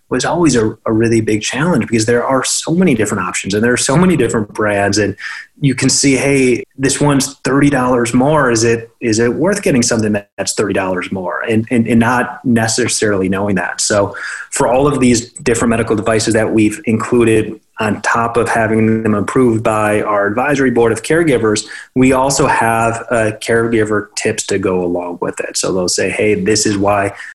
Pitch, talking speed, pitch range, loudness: 115 Hz, 195 wpm, 110-125 Hz, -14 LUFS